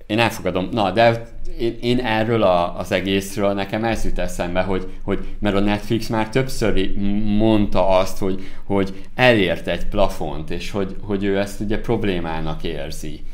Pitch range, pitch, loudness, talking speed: 95-110 Hz, 100 Hz, -21 LUFS, 160 wpm